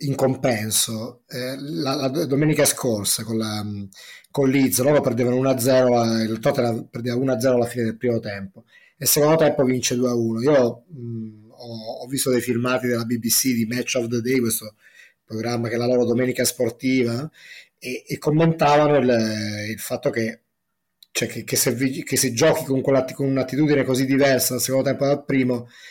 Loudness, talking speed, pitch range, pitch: -21 LUFS, 170 wpm, 115-135 Hz, 125 Hz